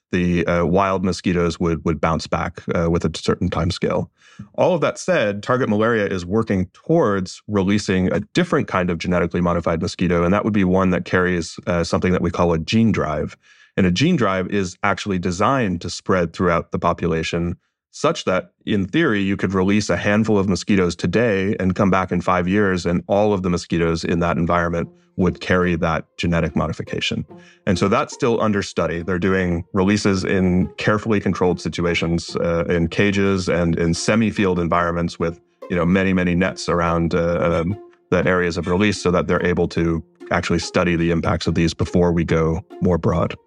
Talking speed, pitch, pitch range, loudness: 190 wpm, 90 Hz, 85-100 Hz, -20 LUFS